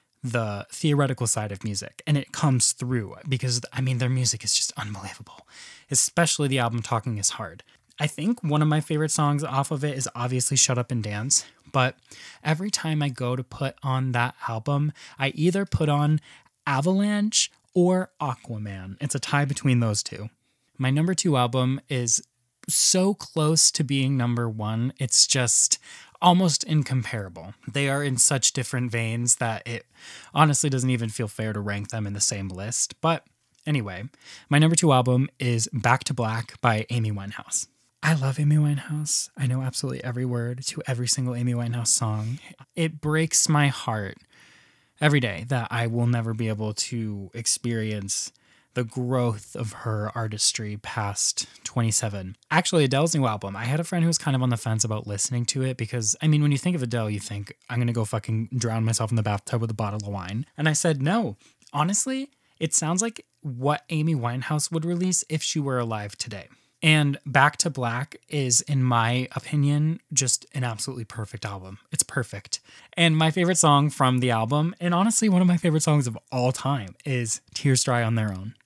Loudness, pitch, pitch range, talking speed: -24 LUFS, 130 Hz, 115-150 Hz, 190 wpm